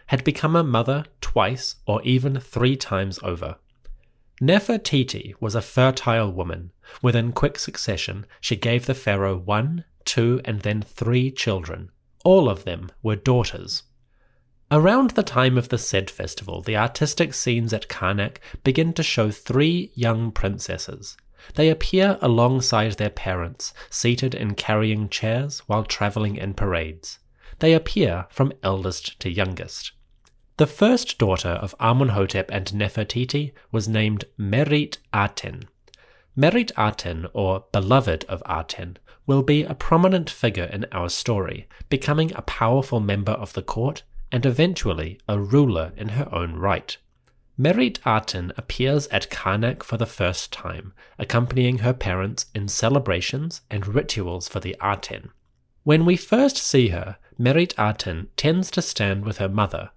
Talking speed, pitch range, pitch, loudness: 140 wpm, 100-135 Hz, 115 Hz, -22 LUFS